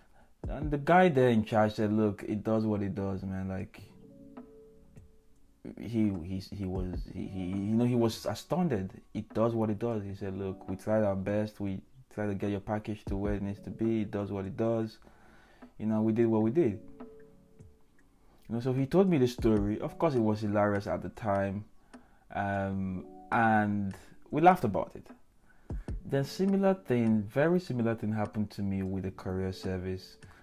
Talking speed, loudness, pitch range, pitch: 190 wpm, -31 LUFS, 95-115 Hz, 105 Hz